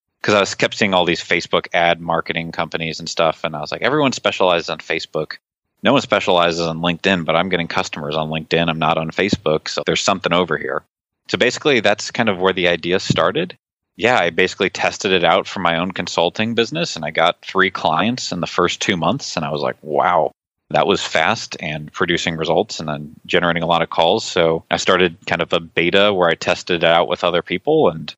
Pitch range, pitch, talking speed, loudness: 80-90 Hz, 85 Hz, 225 wpm, -18 LUFS